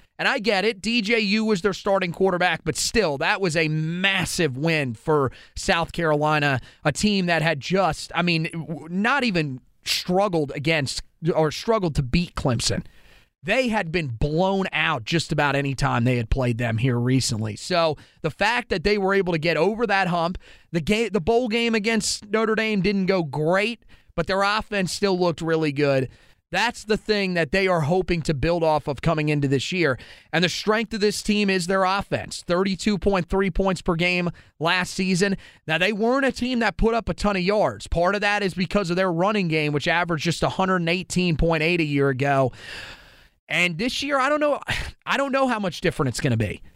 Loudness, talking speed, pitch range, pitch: -22 LUFS, 200 wpm, 155-205 Hz, 180 Hz